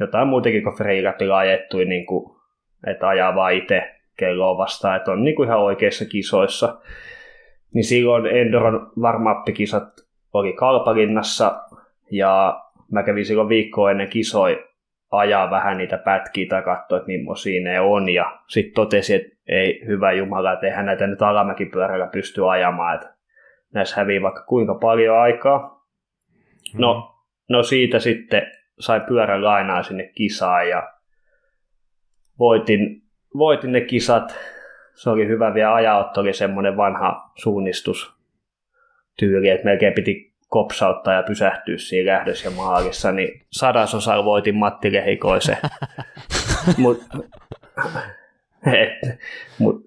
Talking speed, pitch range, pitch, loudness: 125 wpm, 95-115 Hz, 105 Hz, -19 LUFS